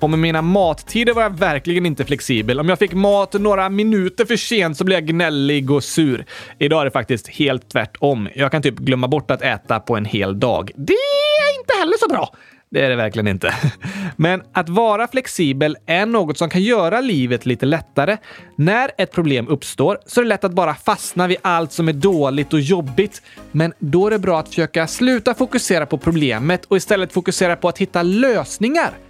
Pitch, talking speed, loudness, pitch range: 170 Hz, 205 wpm, -17 LUFS, 145-200 Hz